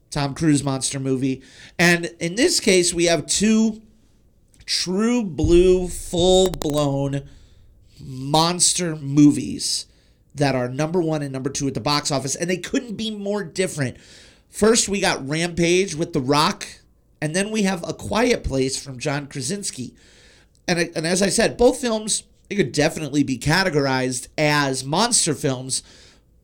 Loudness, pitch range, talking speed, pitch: -20 LUFS, 135-190 Hz, 150 wpm, 155 Hz